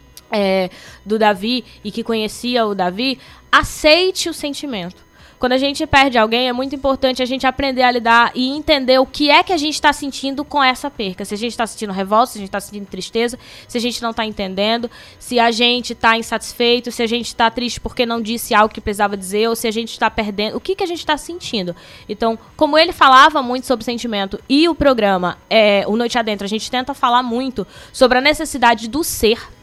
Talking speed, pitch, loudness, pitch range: 215 wpm, 235 Hz, -16 LUFS, 220-265 Hz